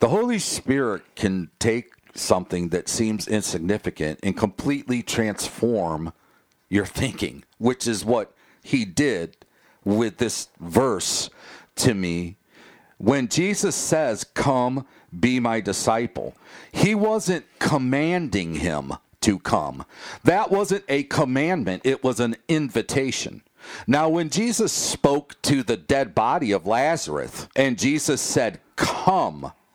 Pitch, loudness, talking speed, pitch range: 125 Hz, -23 LUFS, 120 wpm, 105-150 Hz